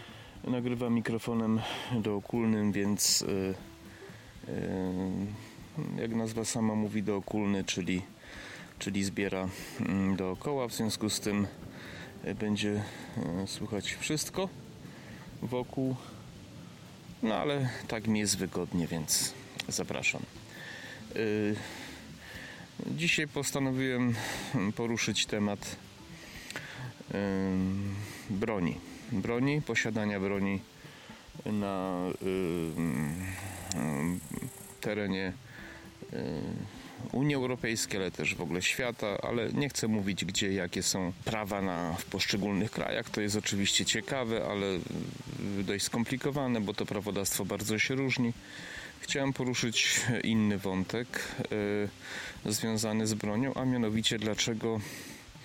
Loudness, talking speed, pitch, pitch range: -32 LUFS, 90 wpm, 105 Hz, 100-120 Hz